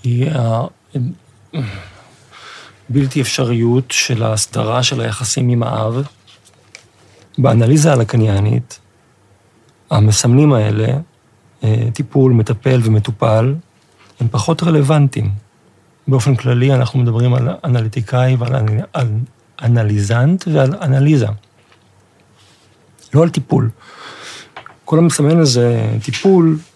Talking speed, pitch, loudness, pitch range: 80 wpm, 120 Hz, -14 LUFS, 110-135 Hz